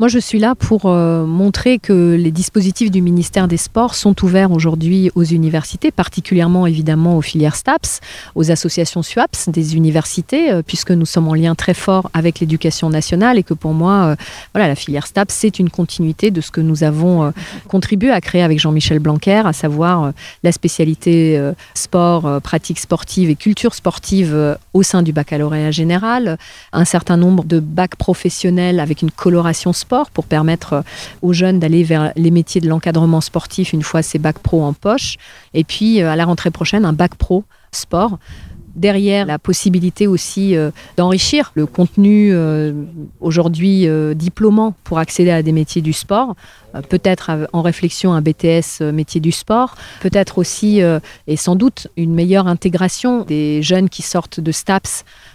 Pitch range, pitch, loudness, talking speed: 160-190 Hz, 170 Hz, -14 LUFS, 170 wpm